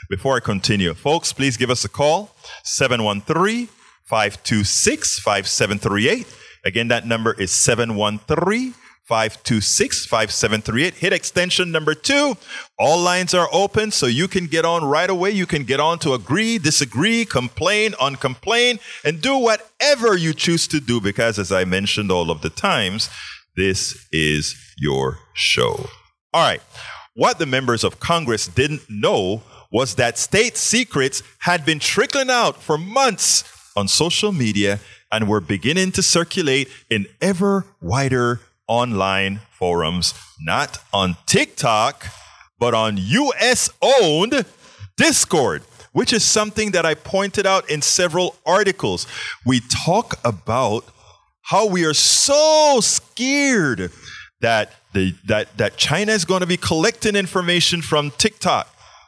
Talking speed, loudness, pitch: 135 wpm, -18 LUFS, 145 Hz